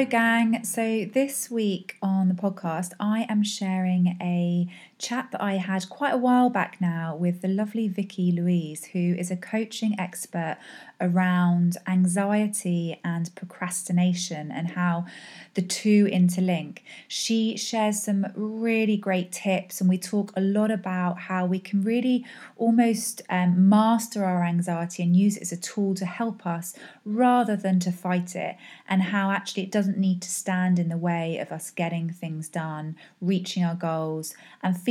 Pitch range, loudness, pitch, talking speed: 175-210 Hz, -25 LUFS, 185 Hz, 165 wpm